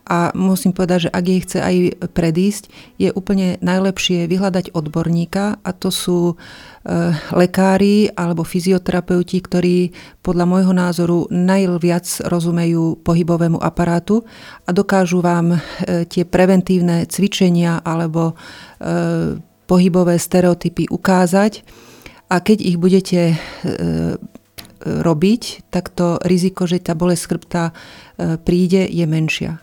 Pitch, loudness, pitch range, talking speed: 180 Hz, -16 LUFS, 170-185 Hz, 115 wpm